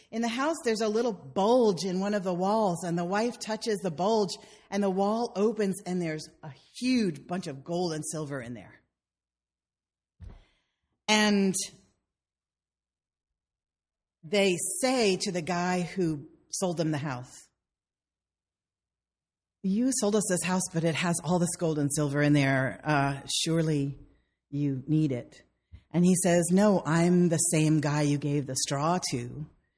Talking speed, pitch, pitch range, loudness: 155 wpm, 170 Hz, 140-195 Hz, -28 LUFS